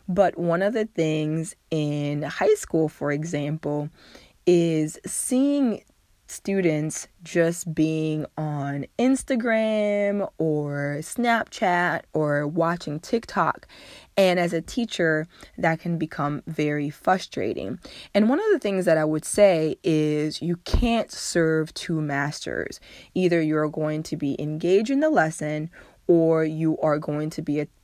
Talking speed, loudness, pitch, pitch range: 135 wpm, -24 LUFS, 160 Hz, 150-190 Hz